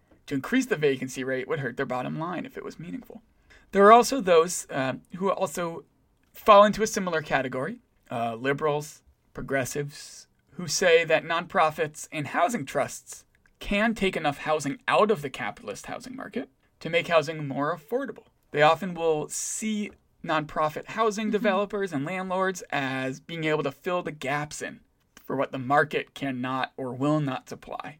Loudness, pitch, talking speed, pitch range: -26 LUFS, 155 Hz, 165 wpm, 140-195 Hz